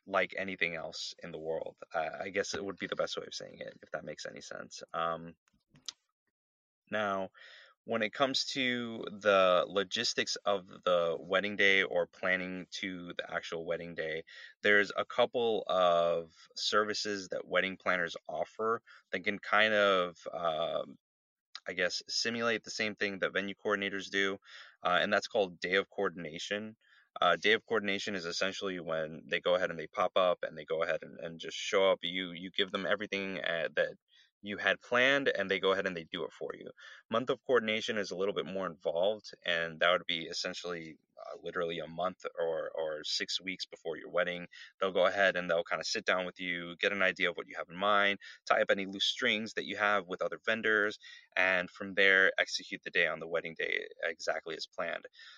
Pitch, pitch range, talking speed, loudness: 100 Hz, 90-115 Hz, 200 wpm, -32 LUFS